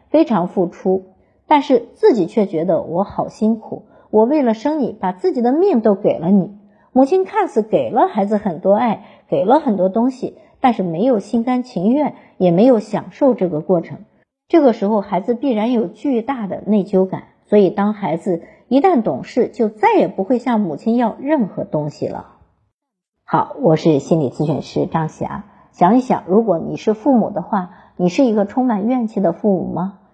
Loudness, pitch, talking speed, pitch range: -17 LUFS, 210 Hz, 270 characters per minute, 185-250 Hz